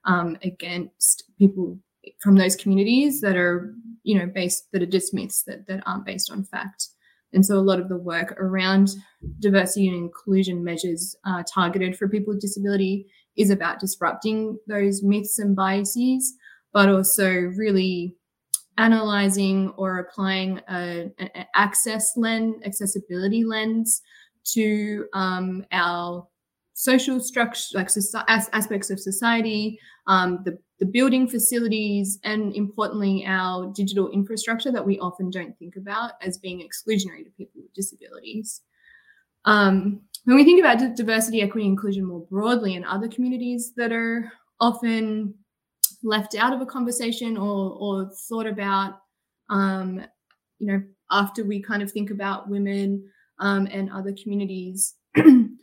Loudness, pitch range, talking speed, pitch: -22 LUFS, 190-220 Hz, 140 wpm, 200 Hz